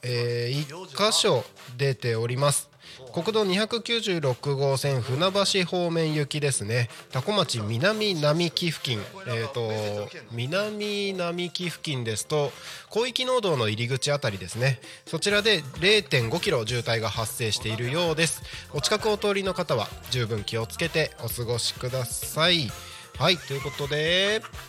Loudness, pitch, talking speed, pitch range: -26 LUFS, 145 Hz, 265 characters per minute, 120-180 Hz